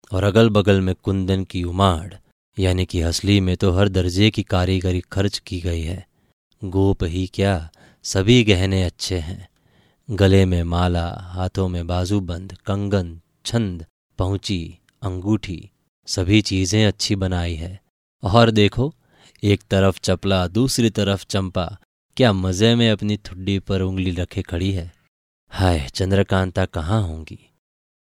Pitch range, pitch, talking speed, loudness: 90-100 Hz, 95 Hz, 135 wpm, -20 LUFS